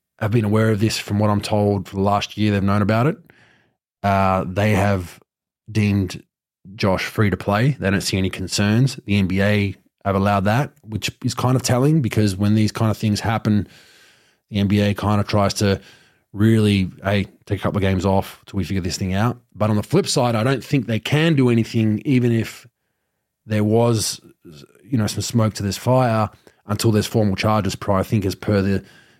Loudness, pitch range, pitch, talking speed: -20 LUFS, 100-115 Hz, 105 Hz, 205 wpm